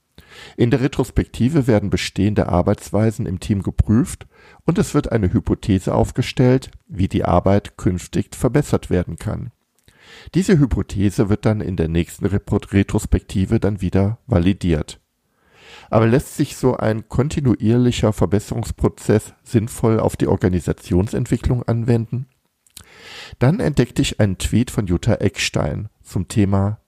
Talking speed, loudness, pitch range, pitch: 125 wpm, -19 LUFS, 95-120 Hz, 105 Hz